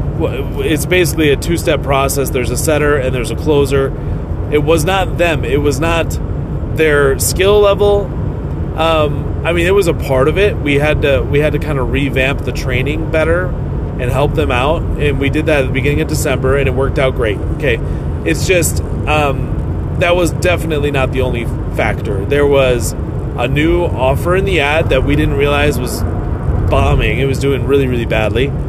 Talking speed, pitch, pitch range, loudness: 190 wpm, 135 Hz, 120-150 Hz, -14 LUFS